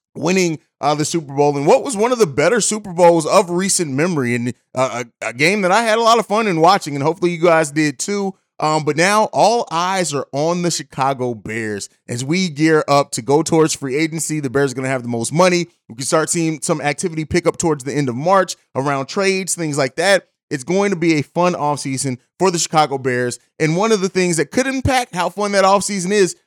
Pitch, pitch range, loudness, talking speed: 160 Hz, 140-185 Hz, -17 LUFS, 245 wpm